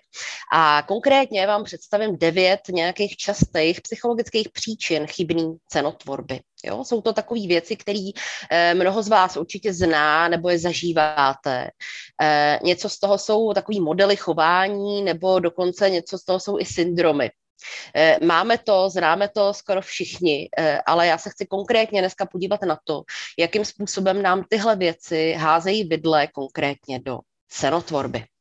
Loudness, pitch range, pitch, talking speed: -21 LUFS, 160-205 Hz, 180 Hz, 135 wpm